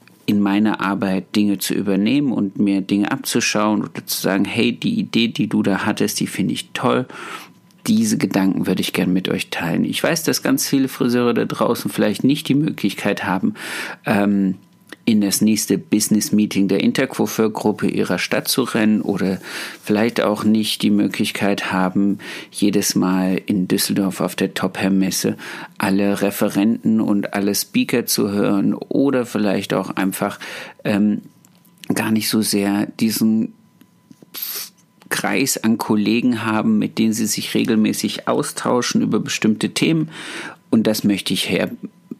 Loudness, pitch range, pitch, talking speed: -19 LUFS, 100-115 Hz, 105 Hz, 150 wpm